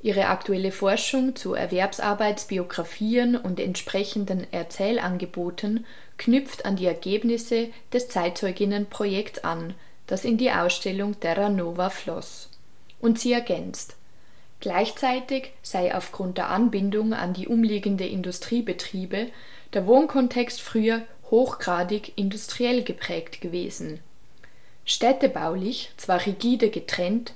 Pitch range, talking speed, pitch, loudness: 185-235 Hz, 100 wpm, 205 Hz, -25 LUFS